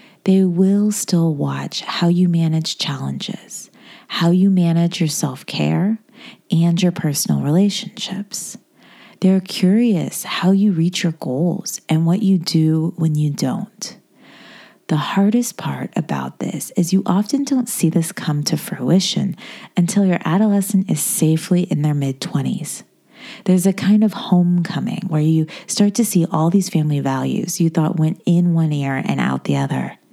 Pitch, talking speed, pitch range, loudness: 180 Hz, 155 wpm, 160-205 Hz, -18 LUFS